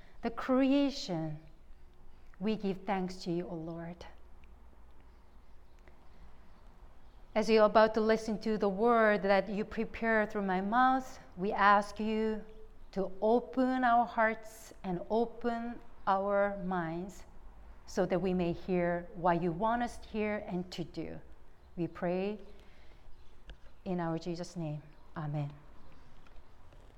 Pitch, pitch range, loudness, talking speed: 185 Hz, 155-220 Hz, -32 LUFS, 125 wpm